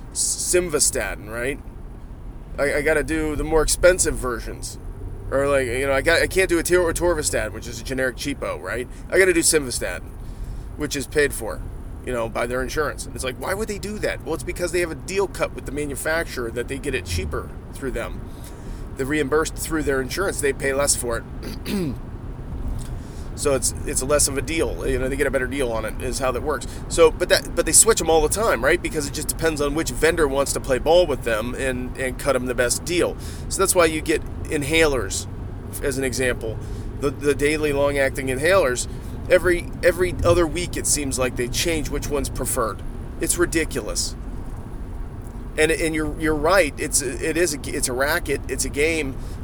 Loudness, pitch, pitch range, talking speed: -22 LUFS, 140 Hz, 125-160 Hz, 210 wpm